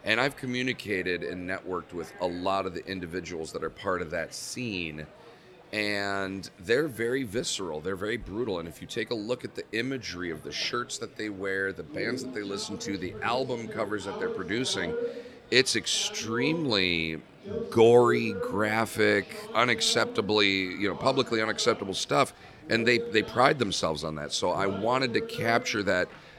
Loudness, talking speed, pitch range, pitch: -28 LUFS, 170 wpm, 95-125 Hz, 105 Hz